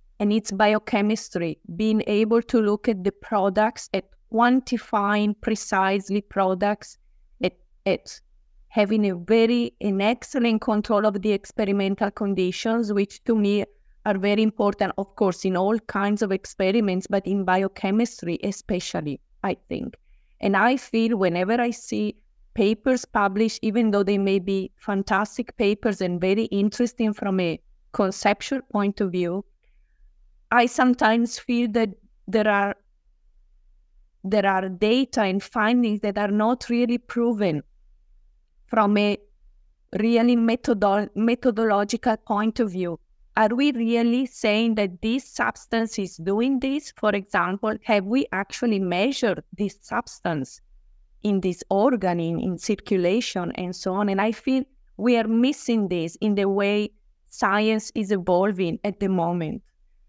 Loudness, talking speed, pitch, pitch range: -23 LUFS, 135 wpm, 210 Hz, 195-230 Hz